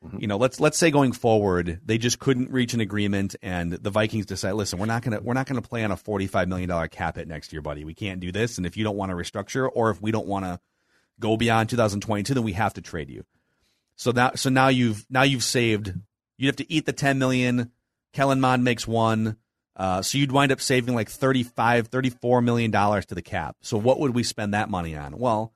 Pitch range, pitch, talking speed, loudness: 100-125 Hz, 110 Hz, 245 wpm, -24 LUFS